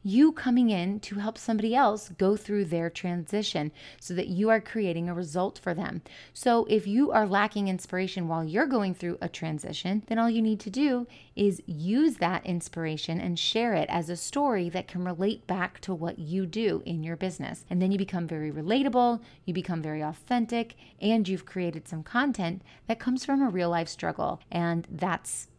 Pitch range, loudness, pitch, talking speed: 170-225 Hz, -29 LUFS, 190 Hz, 195 wpm